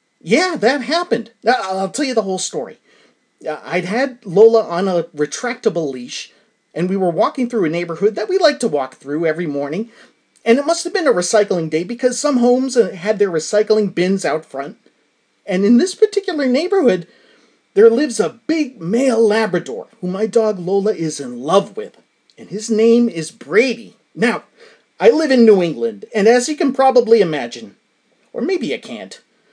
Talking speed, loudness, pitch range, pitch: 180 wpm, -16 LUFS, 180-255 Hz, 220 Hz